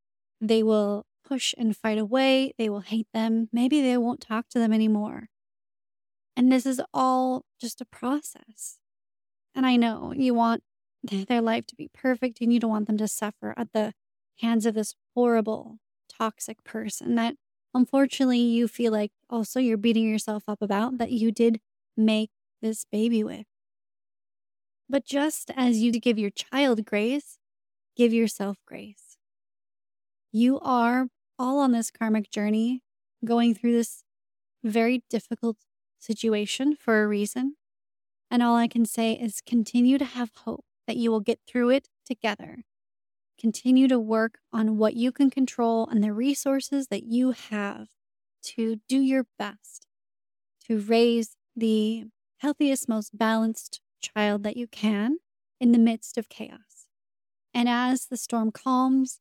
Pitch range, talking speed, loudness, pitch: 215-250 Hz, 150 wpm, -26 LUFS, 230 Hz